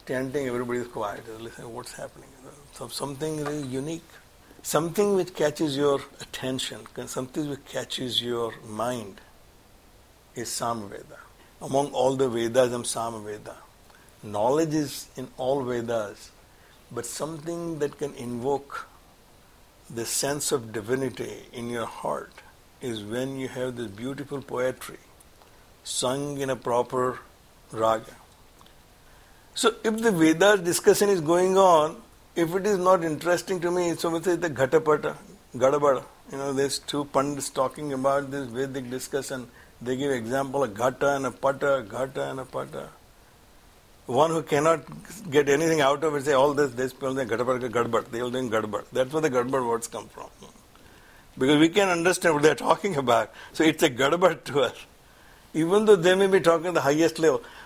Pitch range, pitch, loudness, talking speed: 125-160 Hz, 135 Hz, -25 LUFS, 160 wpm